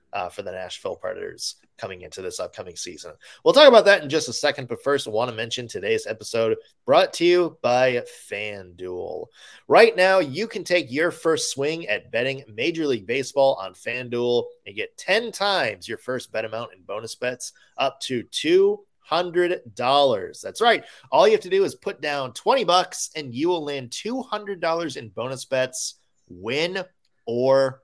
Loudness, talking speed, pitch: -22 LUFS, 175 wpm, 165 Hz